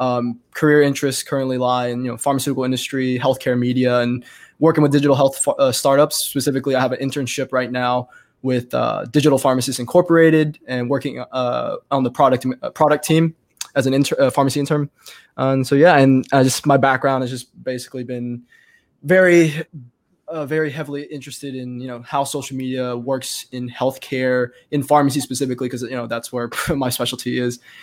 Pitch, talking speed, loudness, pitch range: 135 Hz, 180 wpm, -18 LUFS, 125-145 Hz